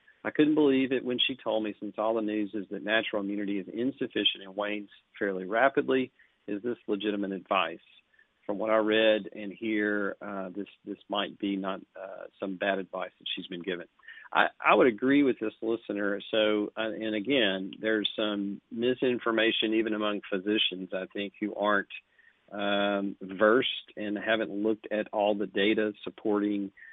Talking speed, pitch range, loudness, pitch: 170 wpm, 100-110 Hz, -29 LUFS, 105 Hz